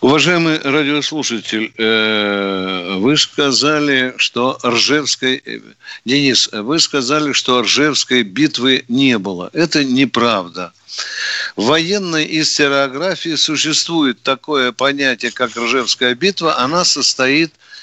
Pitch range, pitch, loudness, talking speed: 125-155 Hz, 135 Hz, -14 LUFS, 90 wpm